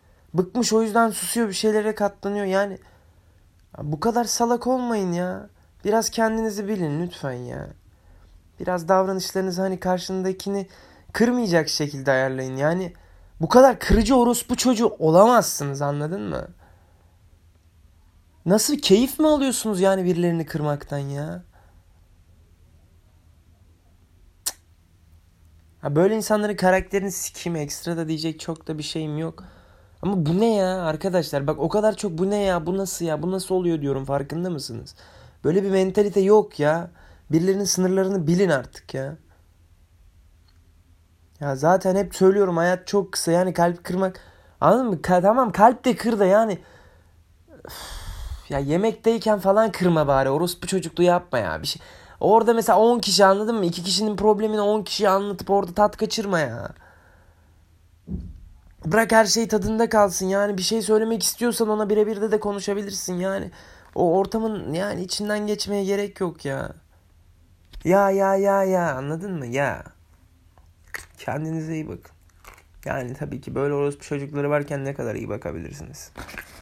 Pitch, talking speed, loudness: 175 Hz, 140 wpm, -22 LUFS